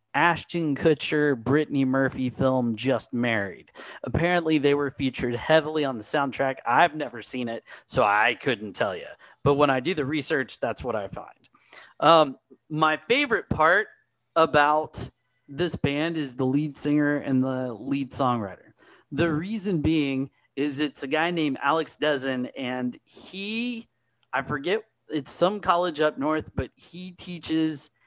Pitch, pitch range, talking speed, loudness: 145 Hz, 130-160 Hz, 150 wpm, -25 LUFS